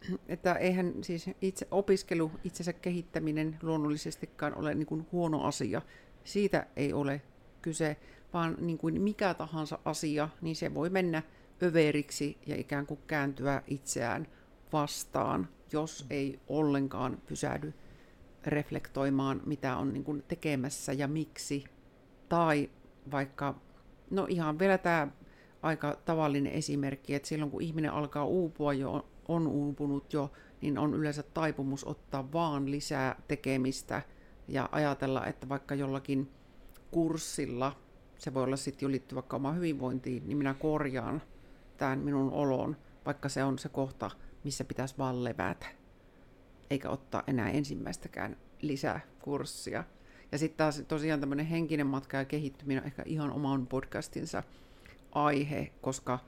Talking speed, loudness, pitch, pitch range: 130 wpm, -34 LUFS, 145 Hz, 135-155 Hz